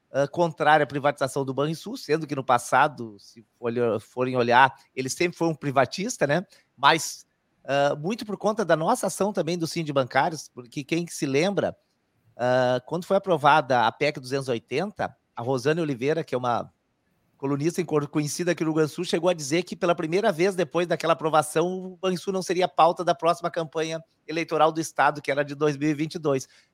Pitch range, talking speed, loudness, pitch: 140-175 Hz, 180 wpm, -25 LUFS, 155 Hz